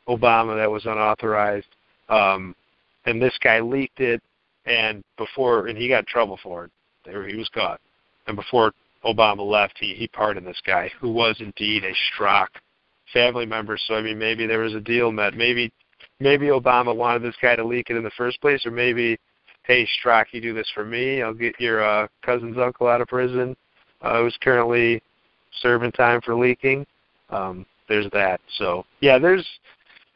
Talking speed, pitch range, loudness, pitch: 180 wpm, 110-120 Hz, -21 LUFS, 115 Hz